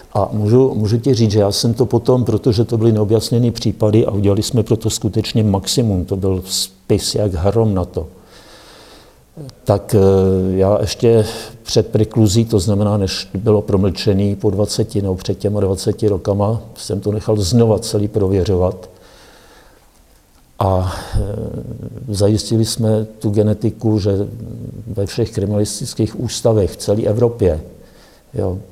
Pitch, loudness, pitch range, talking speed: 105 Hz, -16 LUFS, 100-115 Hz, 135 wpm